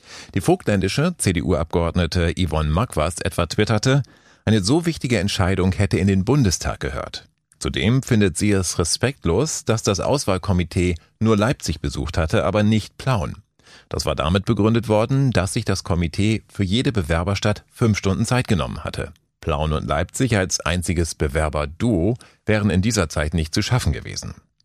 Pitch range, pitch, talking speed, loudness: 85-110 Hz, 100 Hz, 150 wpm, -21 LUFS